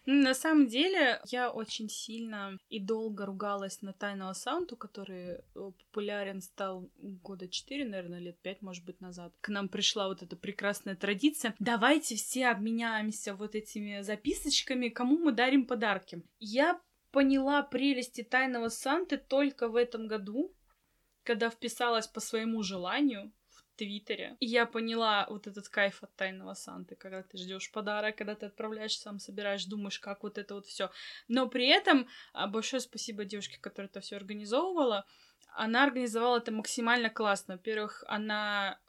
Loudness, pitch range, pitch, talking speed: -32 LUFS, 200-245 Hz, 215 Hz, 150 wpm